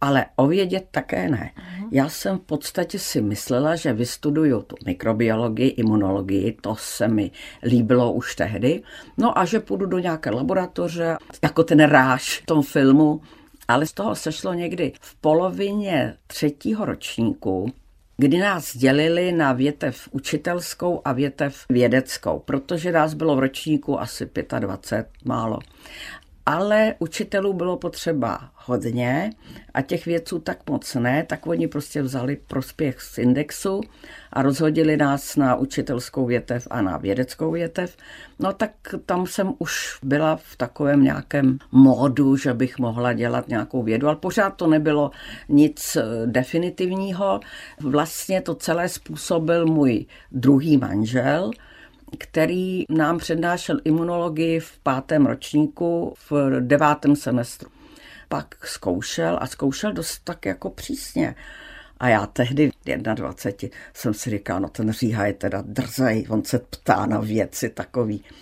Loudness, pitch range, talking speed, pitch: -22 LUFS, 125-170 Hz, 135 wpm, 145 Hz